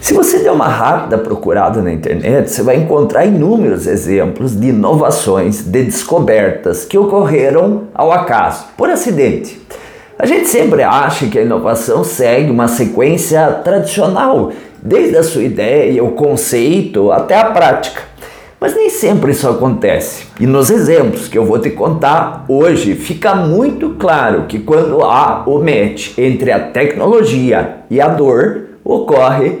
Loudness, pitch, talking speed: -11 LUFS, 195 Hz, 145 wpm